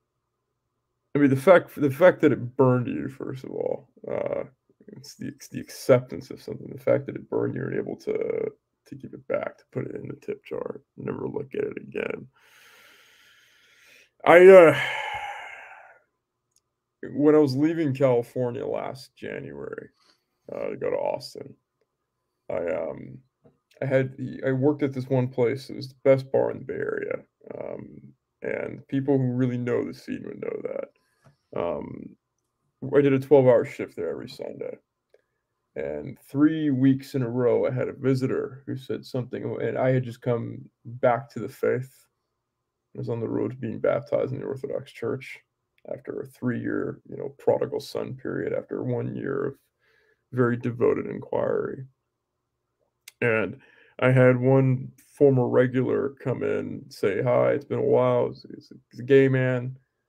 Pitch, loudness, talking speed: 145 Hz, -24 LUFS, 170 wpm